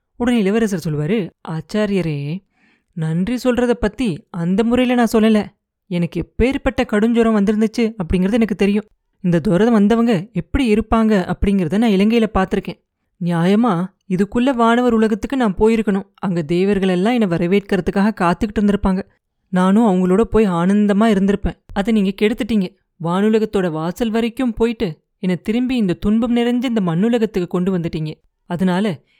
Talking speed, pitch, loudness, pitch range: 125 wpm, 210 Hz, -17 LUFS, 185-230 Hz